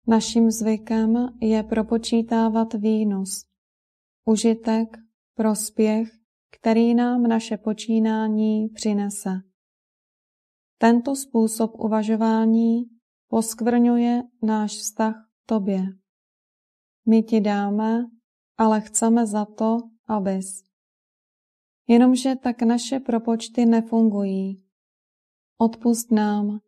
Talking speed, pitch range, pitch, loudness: 80 wpm, 215-230 Hz, 225 Hz, -22 LUFS